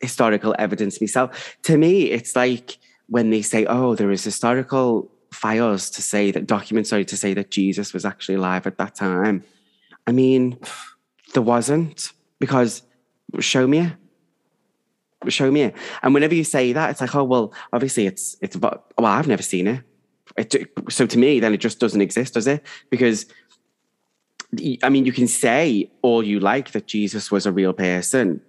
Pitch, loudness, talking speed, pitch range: 120 Hz, -20 LUFS, 175 wpm, 100-130 Hz